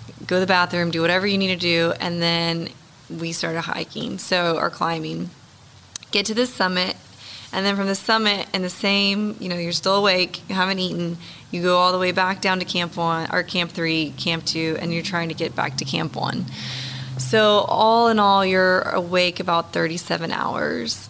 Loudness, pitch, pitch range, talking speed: -21 LUFS, 175 Hz, 165-190 Hz, 200 wpm